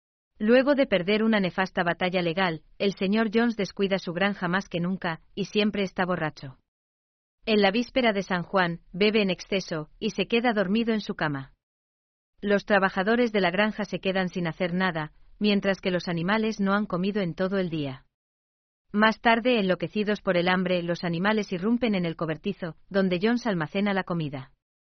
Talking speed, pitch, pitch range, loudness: 180 wpm, 190 Hz, 175-210 Hz, -26 LUFS